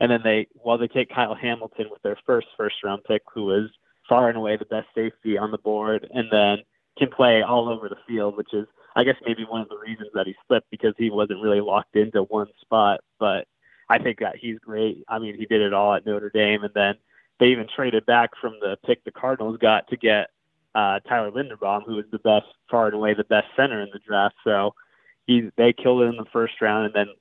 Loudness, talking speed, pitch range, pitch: -23 LUFS, 240 wpm, 105-115 Hz, 110 Hz